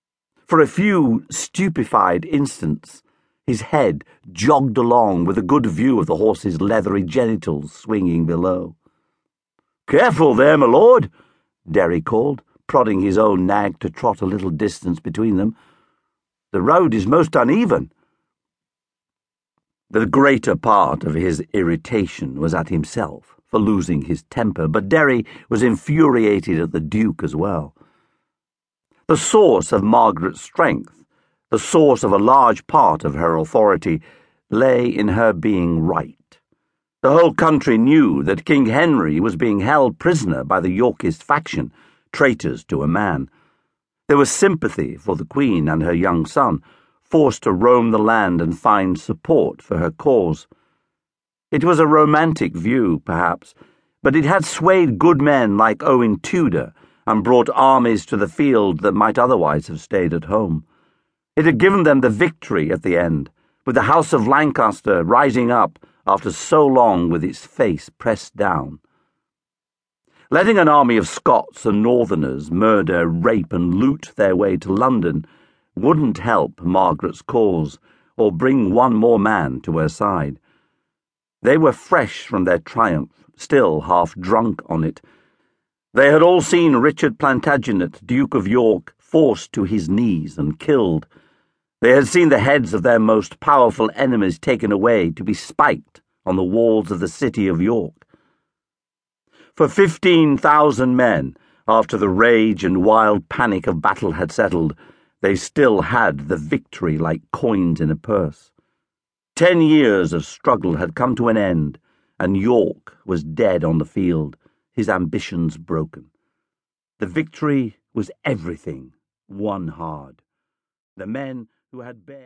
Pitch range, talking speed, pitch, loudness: 85-140 Hz, 150 wpm, 110 Hz, -17 LUFS